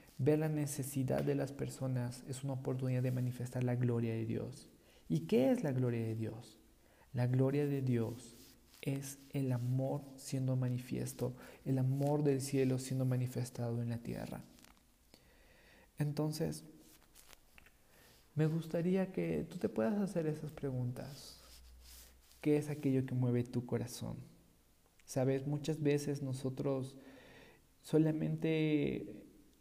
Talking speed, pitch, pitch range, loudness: 125 wpm, 130 Hz, 120-145 Hz, -37 LUFS